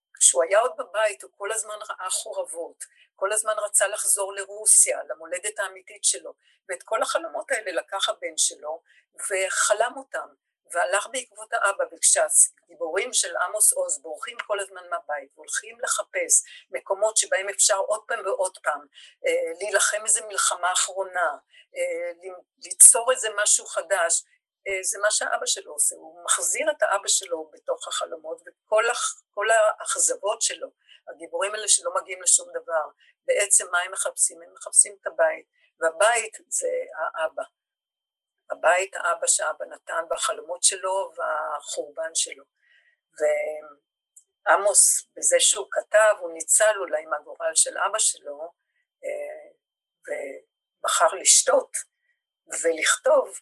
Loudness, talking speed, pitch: -22 LUFS, 120 wpm, 285 Hz